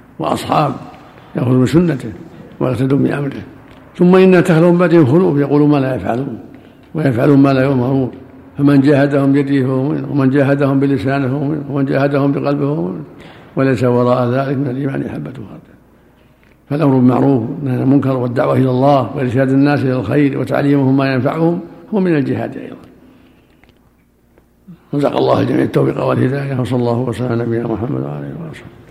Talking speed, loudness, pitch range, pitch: 155 wpm, -14 LUFS, 130-145 Hz, 140 Hz